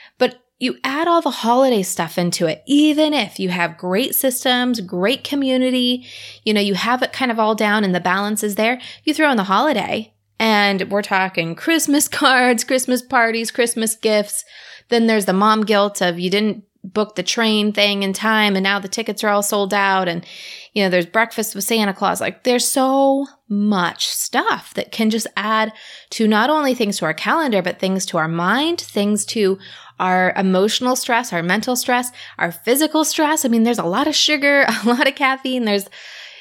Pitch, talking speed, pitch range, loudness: 220 Hz, 195 wpm, 195-255 Hz, -17 LUFS